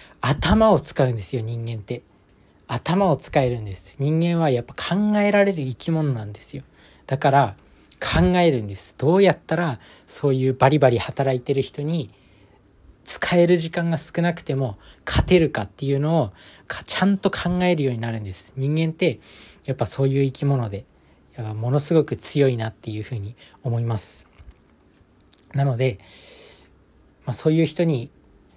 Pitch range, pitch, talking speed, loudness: 105-160 Hz, 130 Hz, 315 characters per minute, -22 LUFS